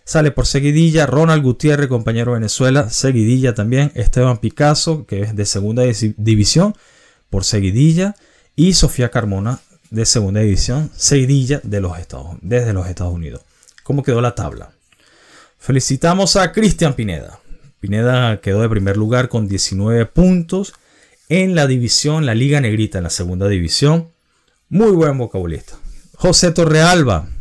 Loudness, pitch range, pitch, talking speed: -15 LUFS, 105-150 Hz, 125 Hz, 140 wpm